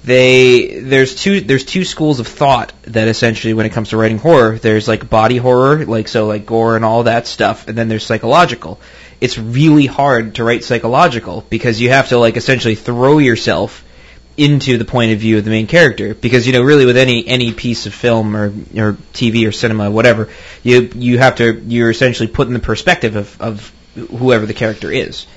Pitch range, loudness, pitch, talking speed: 110-125 Hz, -12 LUFS, 115 Hz, 210 wpm